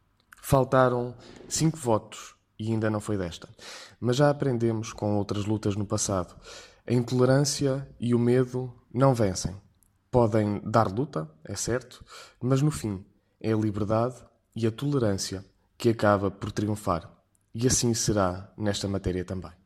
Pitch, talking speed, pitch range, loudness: 110 Hz, 145 wpm, 100-120 Hz, -27 LUFS